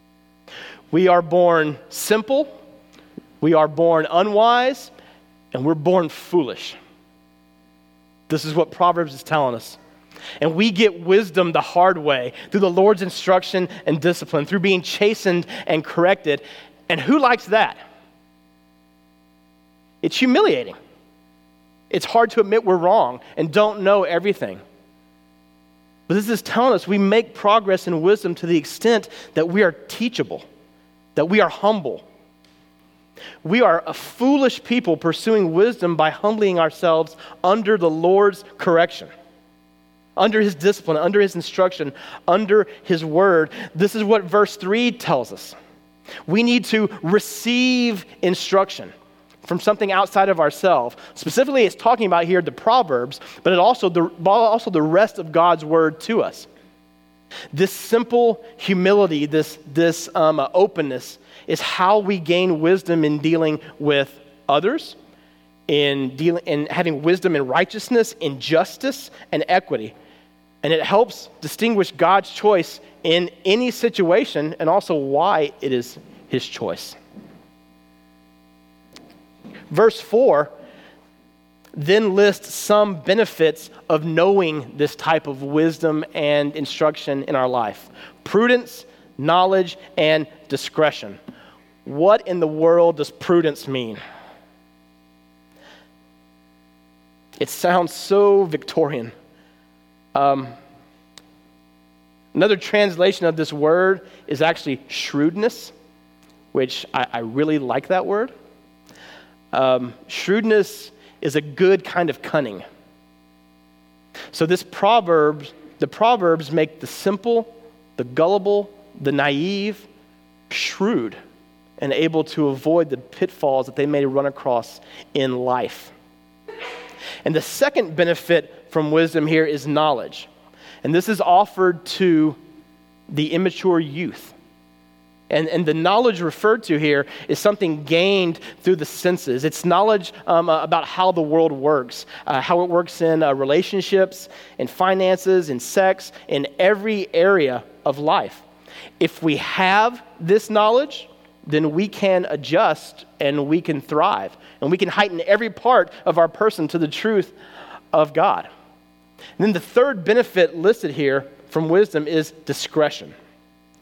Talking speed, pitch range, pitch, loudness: 130 wpm, 125-195 Hz, 160 Hz, -19 LUFS